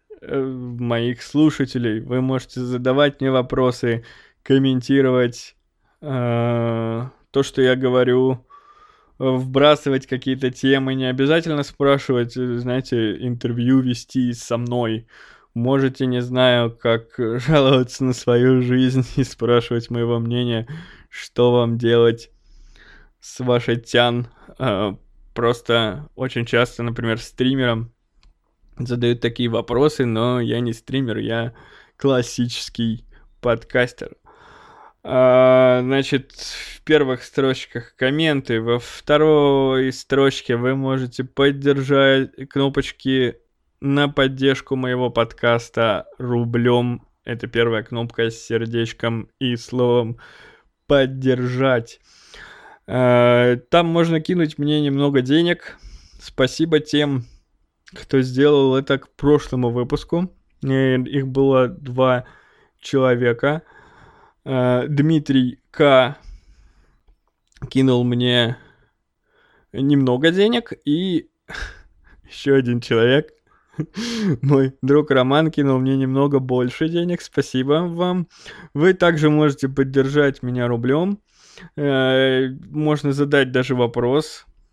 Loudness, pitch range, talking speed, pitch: -19 LUFS, 120-140 Hz, 95 wpm, 130 Hz